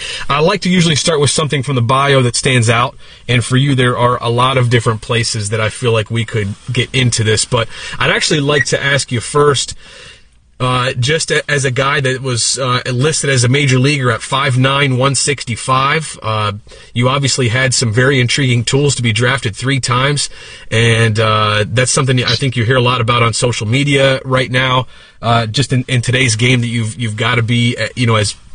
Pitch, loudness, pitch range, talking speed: 125 Hz, -13 LUFS, 115-135 Hz, 220 wpm